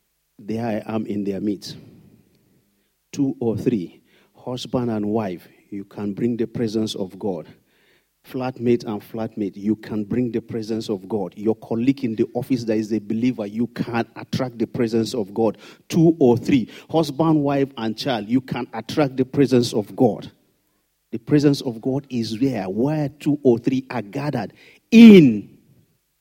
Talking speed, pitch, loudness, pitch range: 165 wpm, 120 Hz, -21 LUFS, 110-135 Hz